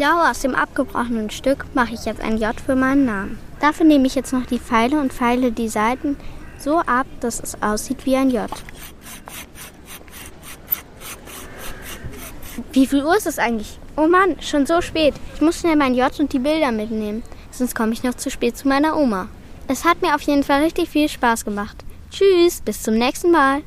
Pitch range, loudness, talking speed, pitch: 240-300 Hz, -19 LUFS, 190 wpm, 270 Hz